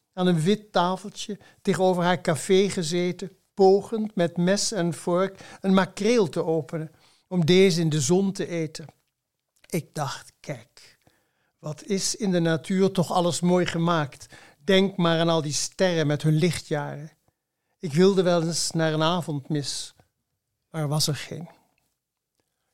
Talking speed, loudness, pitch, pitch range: 155 wpm, -24 LUFS, 175 Hz, 155-190 Hz